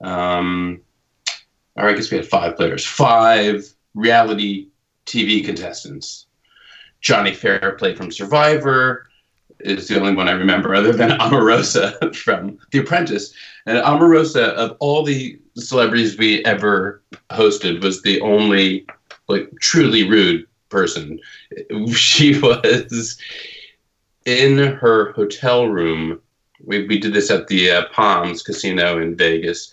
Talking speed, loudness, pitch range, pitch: 125 wpm, -16 LUFS, 100-130 Hz, 110 Hz